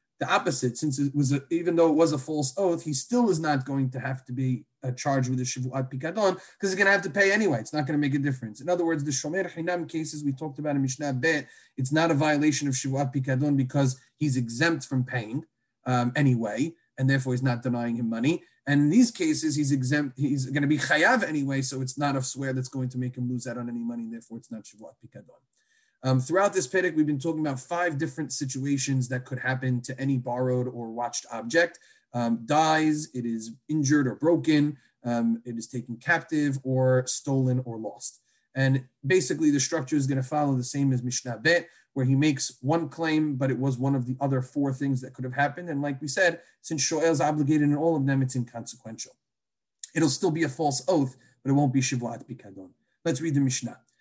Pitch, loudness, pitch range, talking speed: 140 Hz, -26 LUFS, 130-155 Hz, 230 wpm